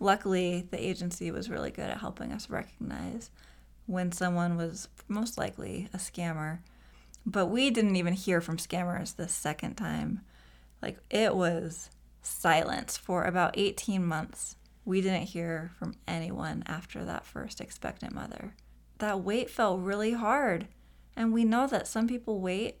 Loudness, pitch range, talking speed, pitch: -32 LUFS, 165-210 Hz, 150 wpm, 185 Hz